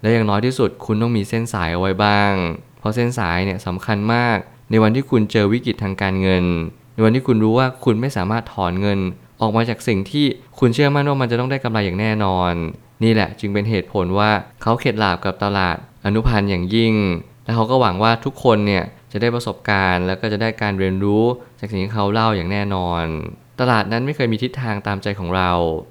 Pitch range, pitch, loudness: 95-120 Hz, 110 Hz, -19 LUFS